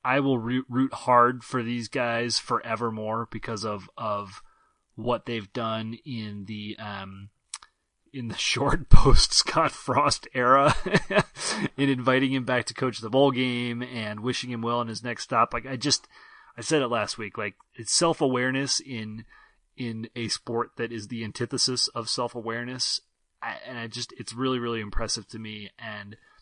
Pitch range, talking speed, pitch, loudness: 110-125 Hz, 170 wpm, 120 Hz, -26 LUFS